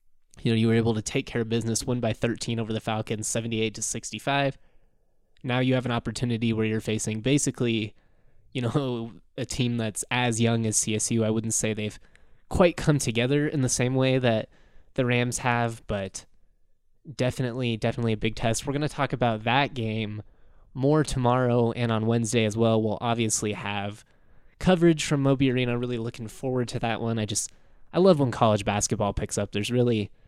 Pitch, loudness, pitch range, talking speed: 115 Hz, -26 LUFS, 110-125 Hz, 190 wpm